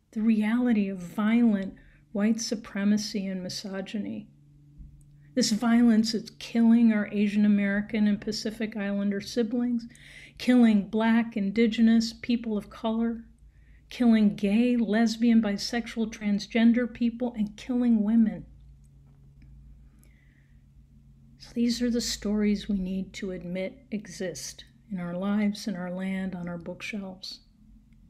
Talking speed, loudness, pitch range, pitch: 115 wpm, -26 LUFS, 190-230 Hz, 210 Hz